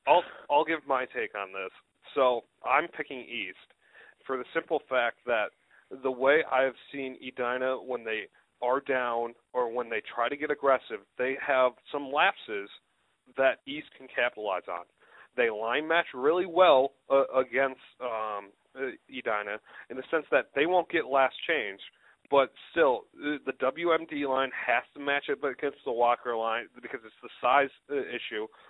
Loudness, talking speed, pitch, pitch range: -29 LUFS, 165 wpm, 130 Hz, 125-150 Hz